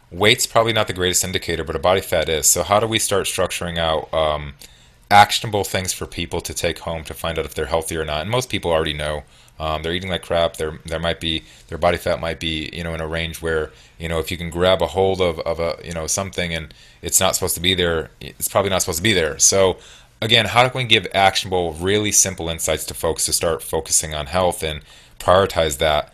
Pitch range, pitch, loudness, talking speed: 80-95 Hz, 85 Hz, -19 LUFS, 245 wpm